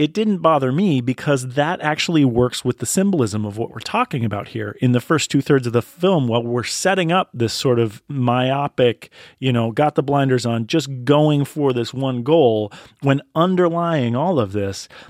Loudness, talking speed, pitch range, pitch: -19 LUFS, 200 wpm, 120-155 Hz, 135 Hz